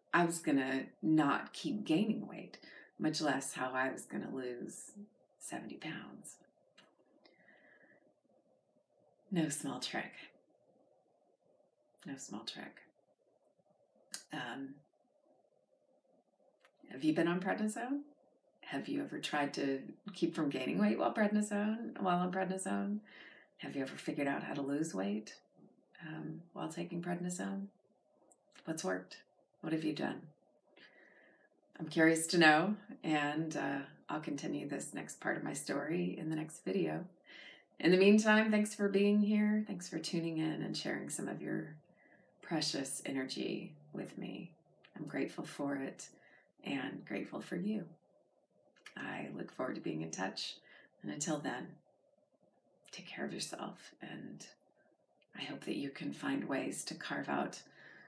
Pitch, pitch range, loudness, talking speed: 170 Hz, 150-205 Hz, -37 LUFS, 135 wpm